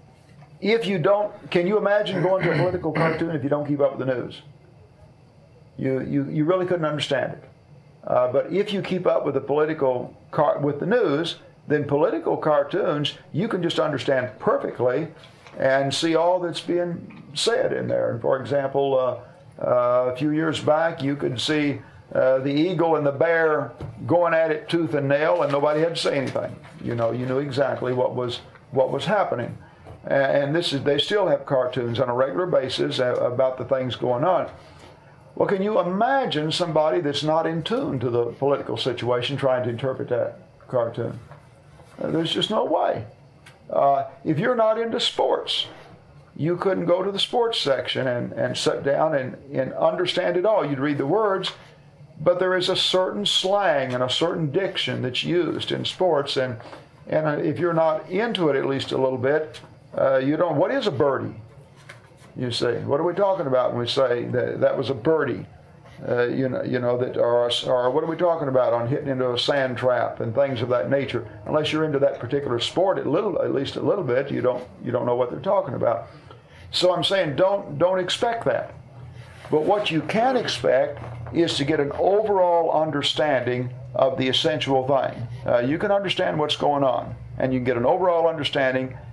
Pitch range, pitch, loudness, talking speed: 130-165 Hz, 145 Hz, -23 LUFS, 195 wpm